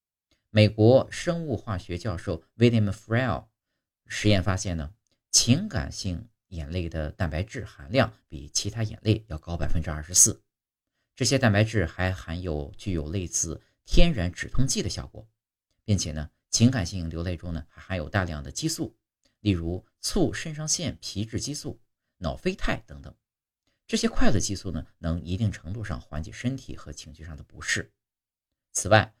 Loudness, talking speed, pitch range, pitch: -27 LUFS, 265 characters per minute, 85-115 Hz, 100 Hz